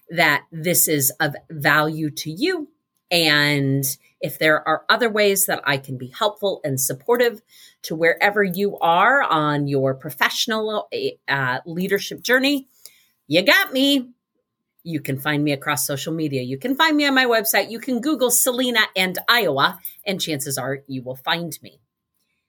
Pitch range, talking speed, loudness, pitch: 150-225 Hz, 160 wpm, -19 LUFS, 170 Hz